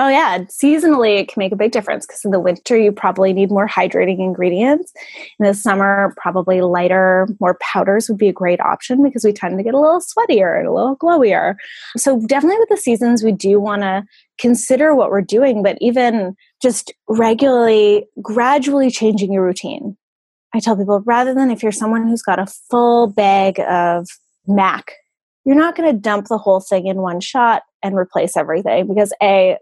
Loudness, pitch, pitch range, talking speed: -15 LUFS, 215 Hz, 195-250 Hz, 190 wpm